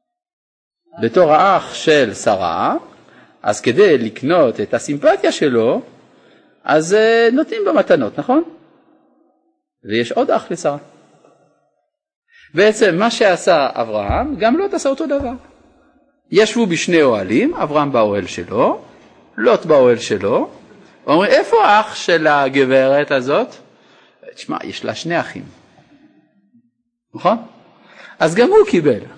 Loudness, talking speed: -15 LUFS, 110 wpm